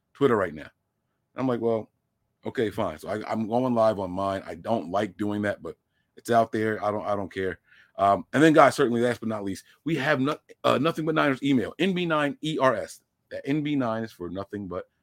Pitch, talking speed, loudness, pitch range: 110 Hz, 215 wpm, -26 LUFS, 100-130 Hz